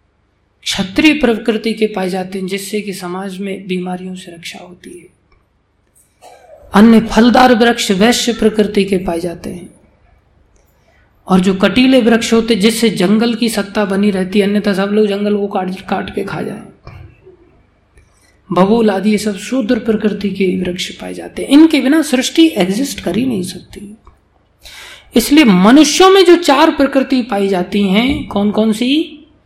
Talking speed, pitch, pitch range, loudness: 155 wpm, 210 Hz, 190-240 Hz, -12 LUFS